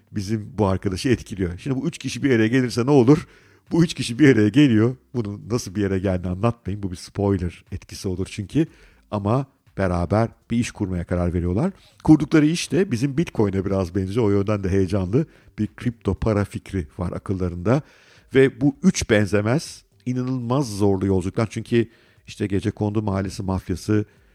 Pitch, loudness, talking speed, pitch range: 105 Hz, -22 LUFS, 165 wpm, 95-125 Hz